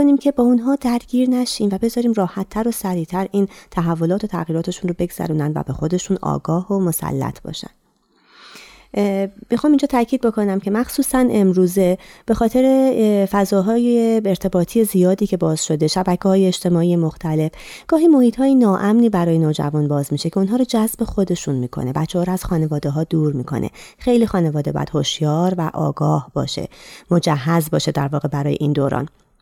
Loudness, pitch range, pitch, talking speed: -18 LUFS, 160-225 Hz, 185 Hz, 160 wpm